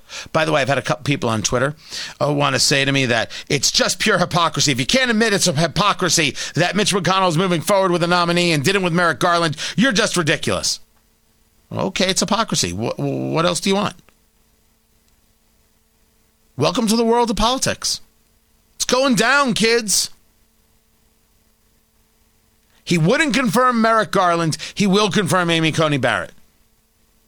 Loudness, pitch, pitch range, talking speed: -17 LUFS, 180 Hz, 150-210 Hz, 165 wpm